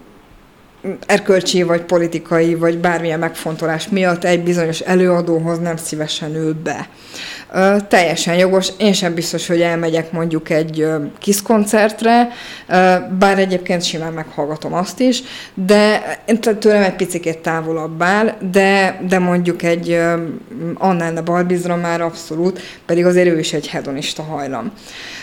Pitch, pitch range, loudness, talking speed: 175 Hz, 165-190 Hz, -16 LUFS, 135 wpm